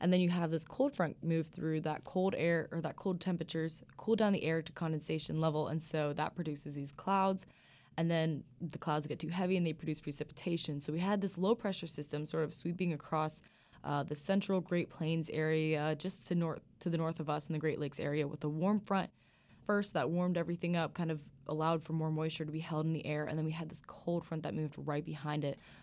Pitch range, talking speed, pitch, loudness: 155-175 Hz, 240 wpm, 160 Hz, -36 LUFS